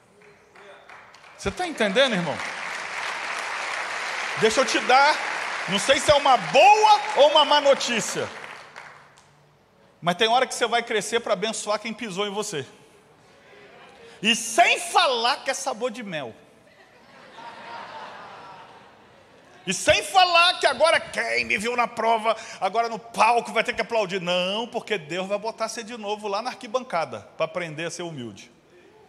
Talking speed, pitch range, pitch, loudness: 150 wpm, 205-270 Hz, 230 Hz, -22 LUFS